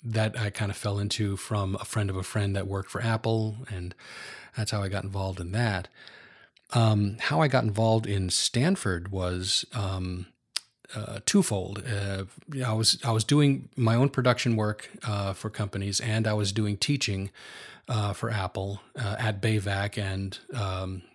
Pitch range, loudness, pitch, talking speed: 95-115 Hz, -28 LUFS, 105 Hz, 175 wpm